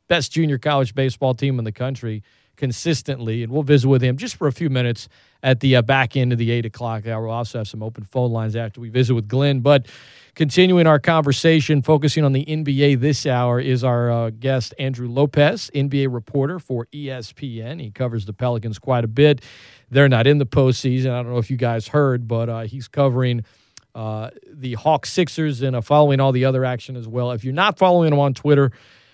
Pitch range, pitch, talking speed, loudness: 120-145 Hz, 130 Hz, 215 wpm, -19 LUFS